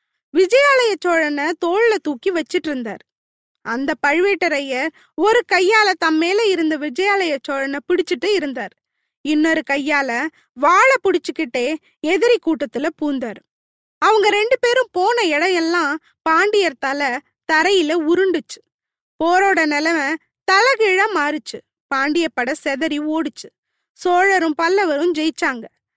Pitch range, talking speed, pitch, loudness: 295-380 Hz, 100 wpm, 330 Hz, -17 LUFS